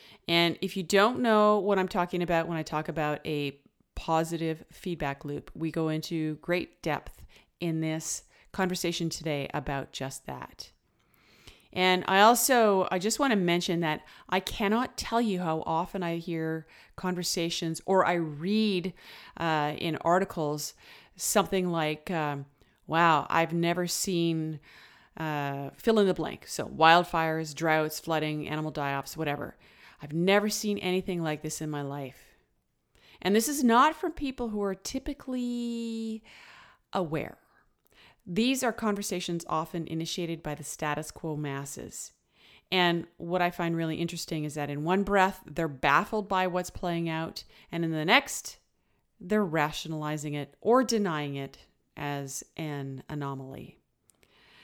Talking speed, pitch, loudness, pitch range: 145 wpm, 165 Hz, -29 LUFS, 155-190 Hz